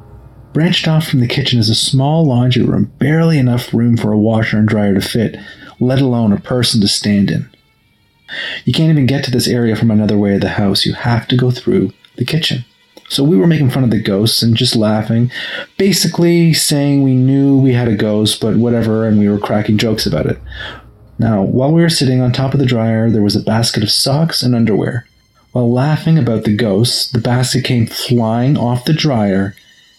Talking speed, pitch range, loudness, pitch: 210 wpm, 110-135 Hz, -13 LUFS, 120 Hz